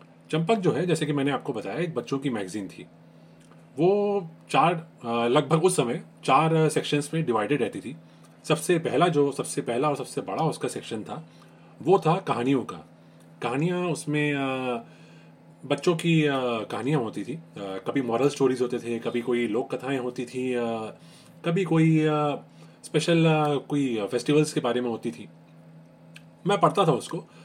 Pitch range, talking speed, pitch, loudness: 100-155 Hz, 155 wpm, 130 Hz, -26 LUFS